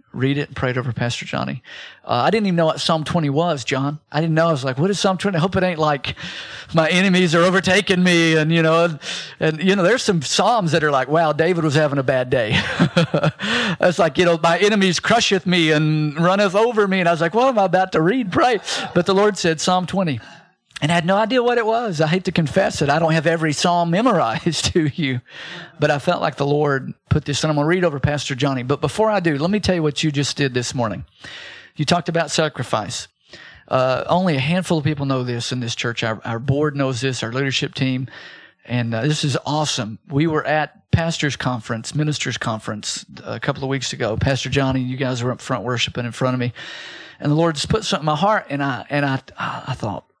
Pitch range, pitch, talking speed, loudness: 135-175 Hz, 155 Hz, 245 wpm, -19 LUFS